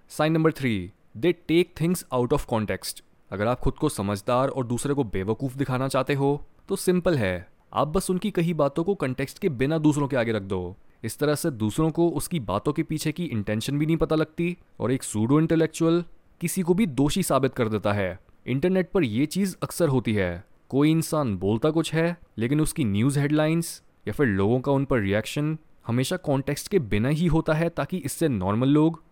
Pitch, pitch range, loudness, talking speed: 145 Hz, 115-165 Hz, -25 LUFS, 205 wpm